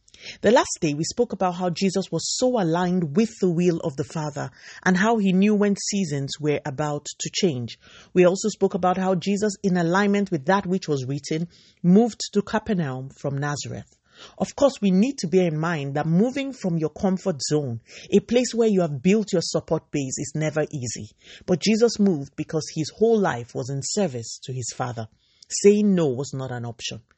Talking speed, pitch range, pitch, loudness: 200 wpm, 145-200 Hz, 175 Hz, -23 LUFS